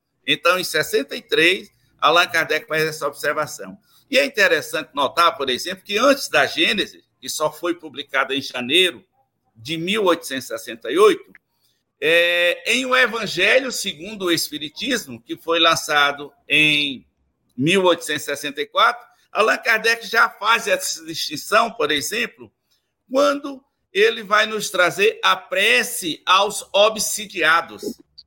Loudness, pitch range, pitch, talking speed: -19 LUFS, 150-245 Hz, 180 Hz, 115 wpm